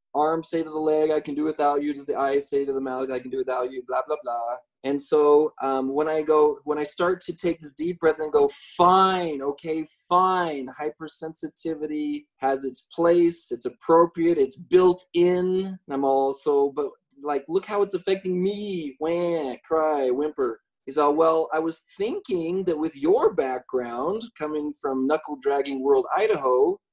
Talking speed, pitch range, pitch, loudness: 180 wpm, 145-185 Hz, 160 Hz, -24 LUFS